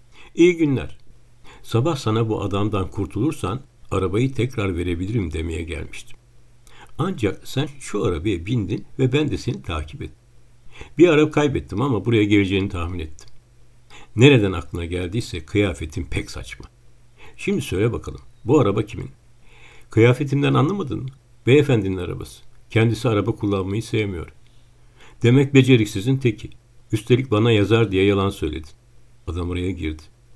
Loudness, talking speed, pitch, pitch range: -21 LUFS, 125 wpm, 115 Hz, 100-120 Hz